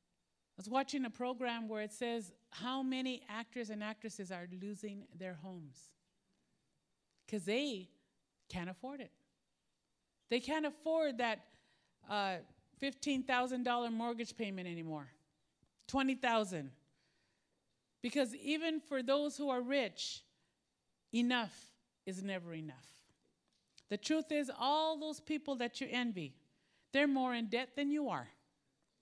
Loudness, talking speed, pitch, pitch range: -39 LUFS, 120 wpm, 235 Hz, 190-270 Hz